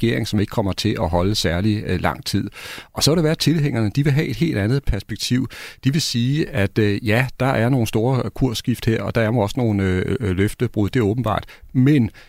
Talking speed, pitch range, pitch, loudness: 240 wpm, 105-130 Hz, 115 Hz, -20 LUFS